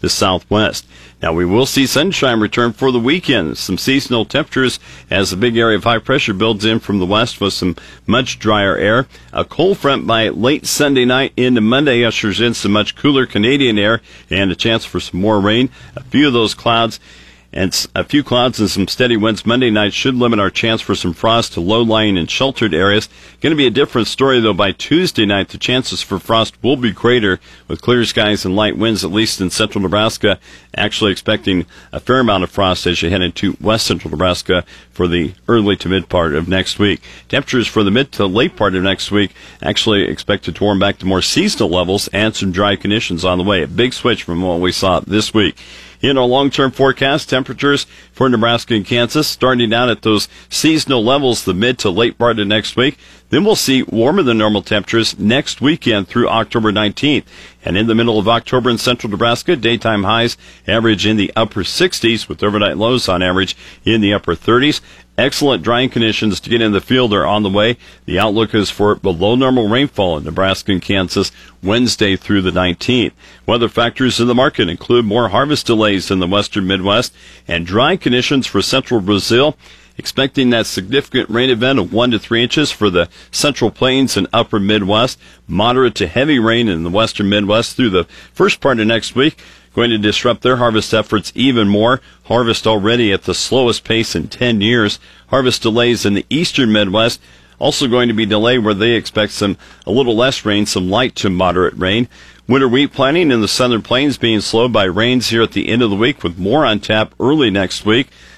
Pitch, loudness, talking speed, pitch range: 110 Hz, -14 LUFS, 205 wpm, 95-120 Hz